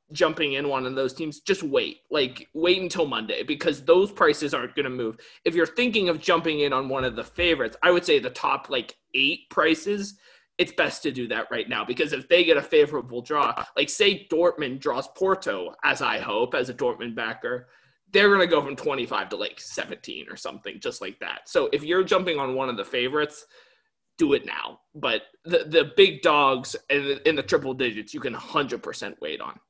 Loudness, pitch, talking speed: -24 LUFS, 180 Hz, 215 wpm